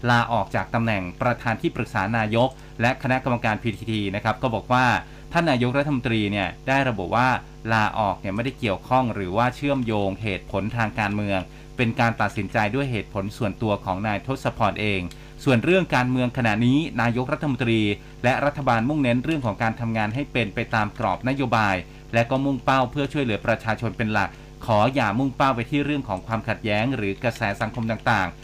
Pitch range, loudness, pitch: 105-130 Hz, -23 LUFS, 115 Hz